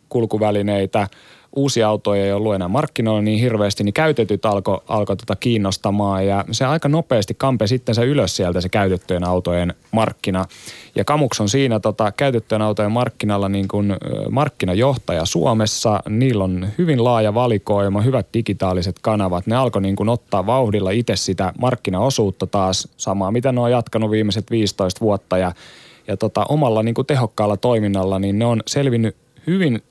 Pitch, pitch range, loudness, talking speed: 105 Hz, 100-120 Hz, -19 LUFS, 160 wpm